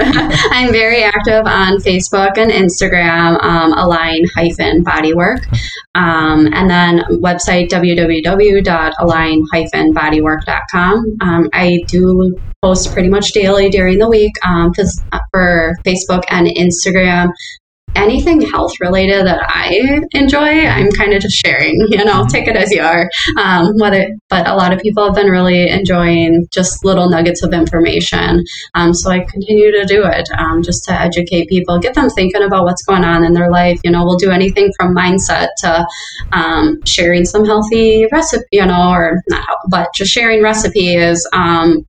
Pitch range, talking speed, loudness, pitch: 170-200 Hz, 155 wpm, -11 LUFS, 180 Hz